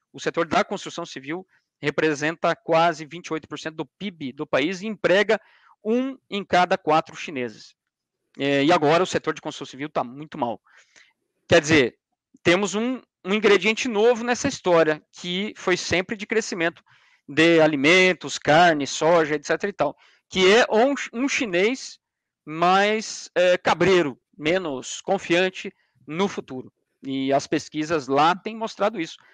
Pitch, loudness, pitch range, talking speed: 170 Hz, -22 LUFS, 155-205 Hz, 140 wpm